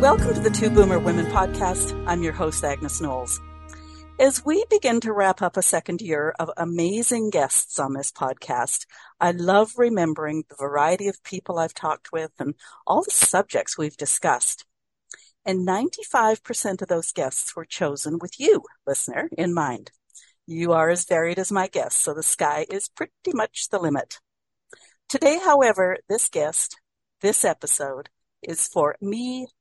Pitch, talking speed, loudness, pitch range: 185 Hz, 160 wpm, -22 LUFS, 160-230 Hz